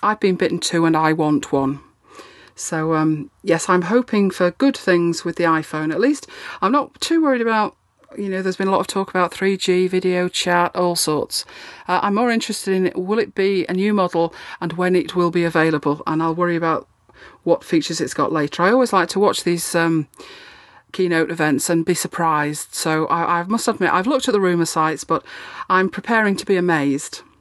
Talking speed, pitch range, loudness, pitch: 210 wpm, 165-200 Hz, -19 LUFS, 180 Hz